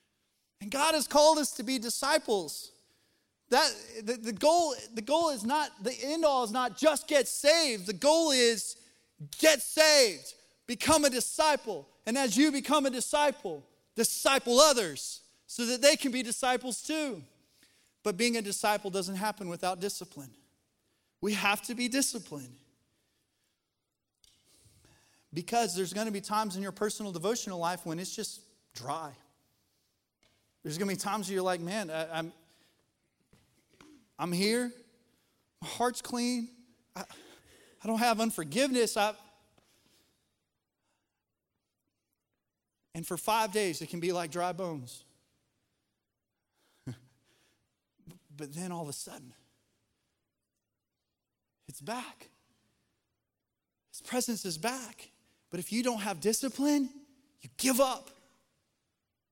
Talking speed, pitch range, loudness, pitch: 130 wpm, 170-260 Hz, -29 LUFS, 220 Hz